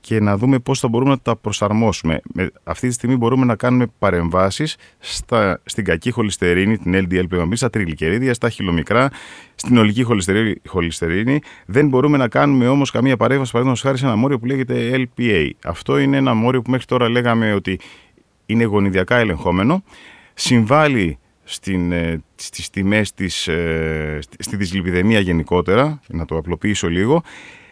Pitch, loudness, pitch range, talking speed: 110 Hz, -18 LUFS, 90-125 Hz, 155 wpm